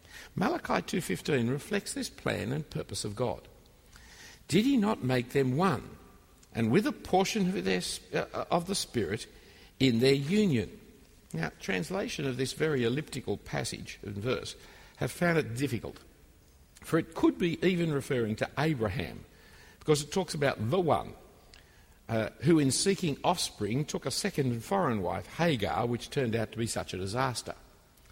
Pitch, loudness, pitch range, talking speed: 135 Hz, -31 LUFS, 110-165 Hz, 160 wpm